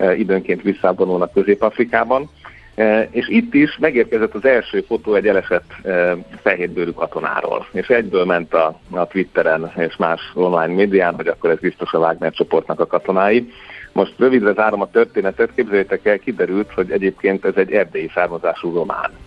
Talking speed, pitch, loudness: 155 wpm, 110 Hz, -17 LUFS